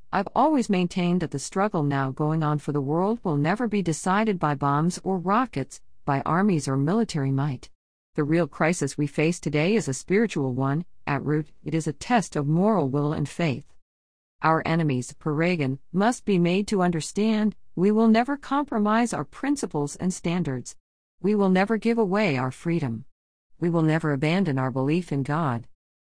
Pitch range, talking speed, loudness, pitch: 140-195 Hz, 180 wpm, -25 LUFS, 160 Hz